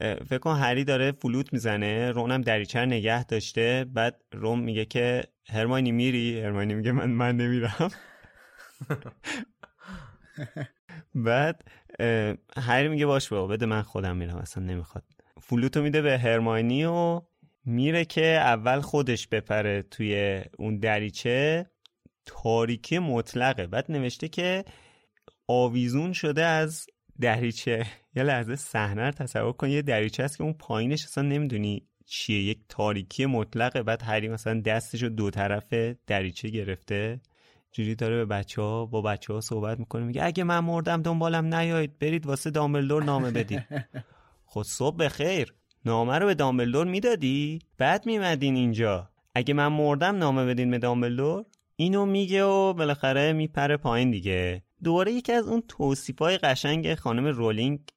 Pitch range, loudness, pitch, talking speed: 110-150 Hz, -27 LUFS, 125 Hz, 145 wpm